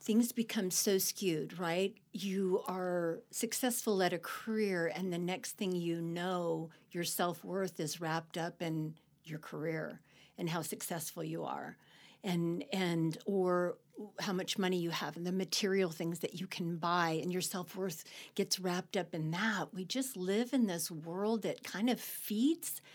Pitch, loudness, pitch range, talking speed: 180 Hz, -36 LUFS, 170-200 Hz, 175 wpm